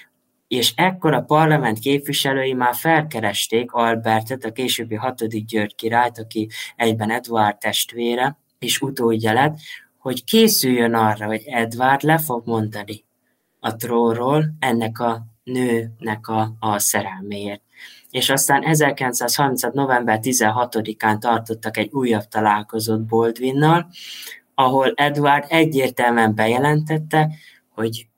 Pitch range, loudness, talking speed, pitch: 110-135 Hz, -19 LUFS, 110 wpm, 120 Hz